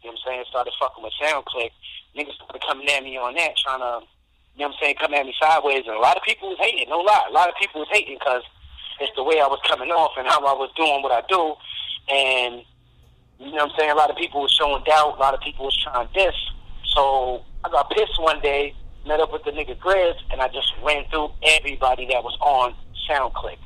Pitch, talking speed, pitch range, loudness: 140 Hz, 255 wpm, 125-155 Hz, -21 LUFS